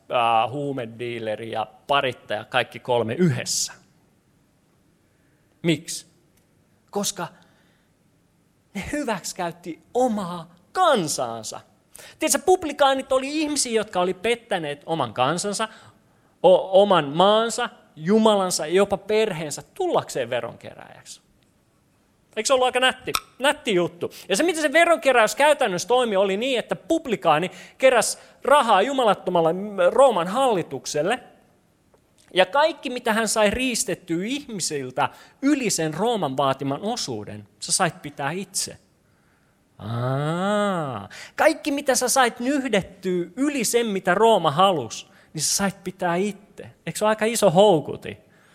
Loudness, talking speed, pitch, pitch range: -22 LUFS, 115 wpm, 195 Hz, 160-240 Hz